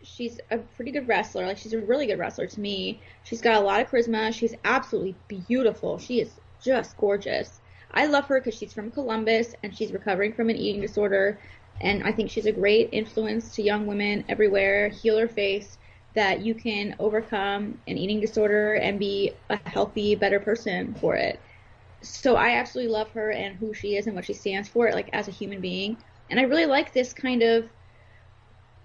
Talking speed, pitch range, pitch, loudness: 195 wpm, 200-230 Hz, 215 Hz, -25 LUFS